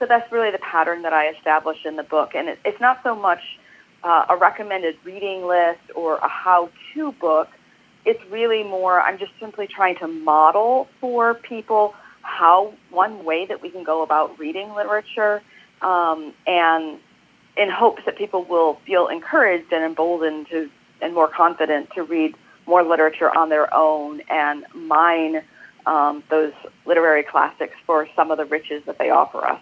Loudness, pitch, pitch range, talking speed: -20 LUFS, 170 Hz, 155-205 Hz, 170 wpm